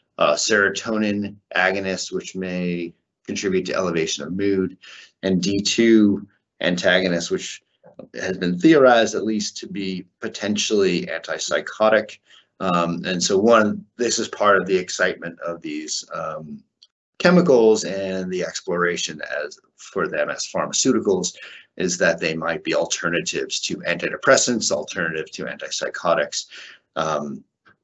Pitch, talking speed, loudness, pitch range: 100 Hz, 125 wpm, -21 LUFS, 90-110 Hz